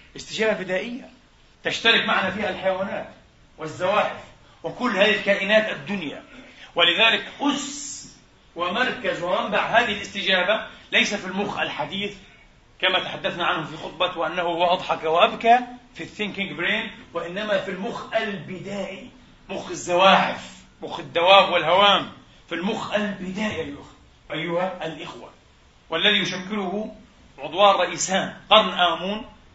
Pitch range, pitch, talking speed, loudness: 180-215 Hz, 200 Hz, 105 wpm, -22 LUFS